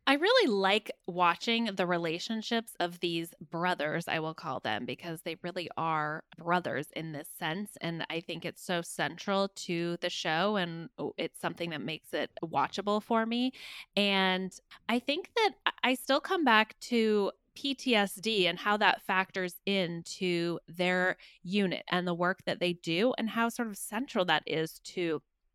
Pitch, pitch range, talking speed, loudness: 185 Hz, 170-215 Hz, 165 wpm, -31 LUFS